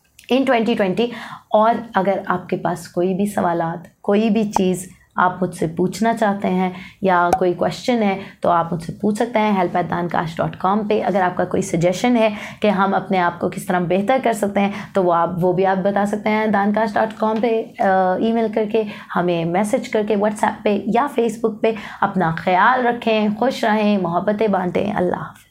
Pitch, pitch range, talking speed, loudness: 200 Hz, 180-220 Hz, 175 wpm, -19 LUFS